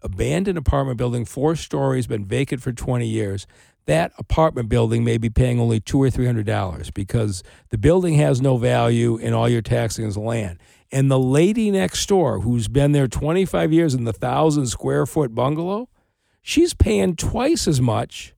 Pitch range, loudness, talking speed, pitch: 115-150 Hz, -20 LUFS, 185 wpm, 125 Hz